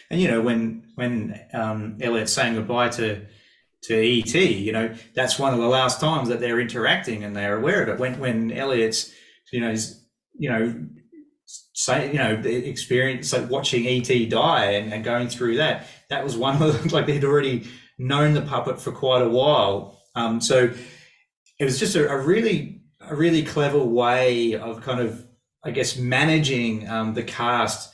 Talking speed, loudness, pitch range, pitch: 185 wpm, -22 LUFS, 115-130 Hz, 120 Hz